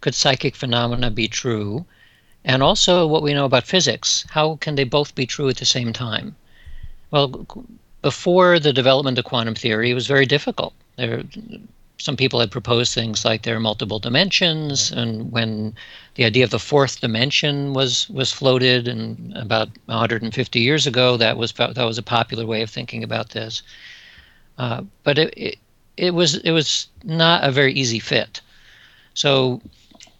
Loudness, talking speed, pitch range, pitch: -19 LUFS, 170 wpm, 115-145 Hz, 125 Hz